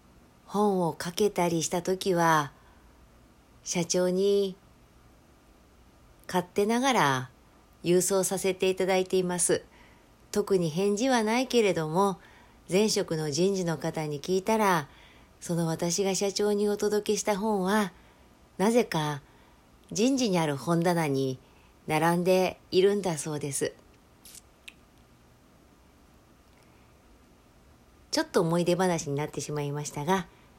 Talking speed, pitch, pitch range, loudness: 215 characters per minute, 175 Hz, 140-195 Hz, -27 LUFS